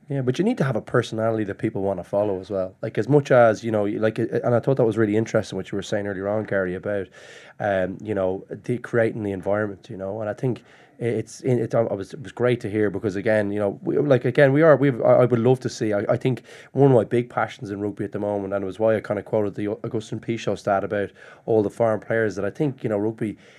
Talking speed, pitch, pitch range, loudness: 285 wpm, 110 Hz, 100-120 Hz, -23 LUFS